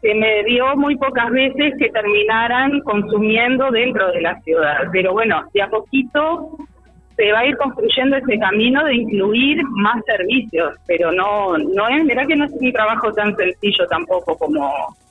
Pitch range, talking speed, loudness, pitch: 205-270 Hz, 170 wpm, -16 LUFS, 225 Hz